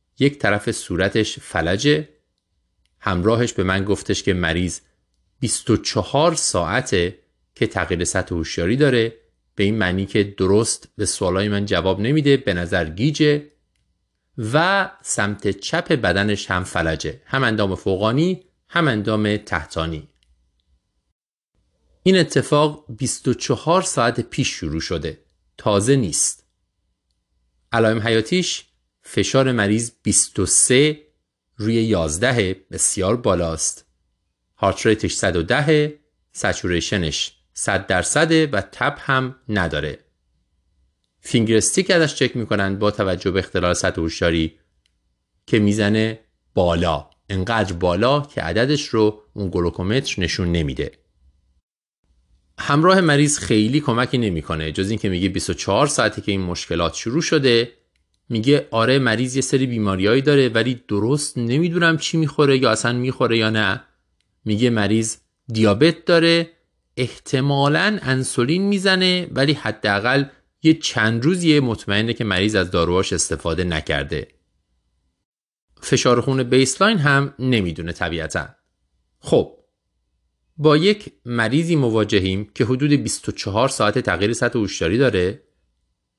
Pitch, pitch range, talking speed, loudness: 110 Hz, 90-135 Hz, 110 wpm, -19 LUFS